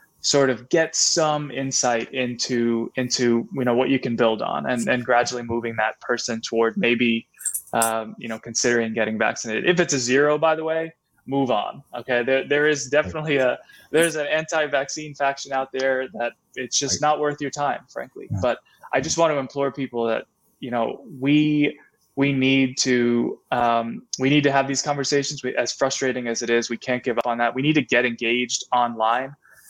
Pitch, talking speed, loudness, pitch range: 130 Hz, 195 wpm, -22 LUFS, 120-145 Hz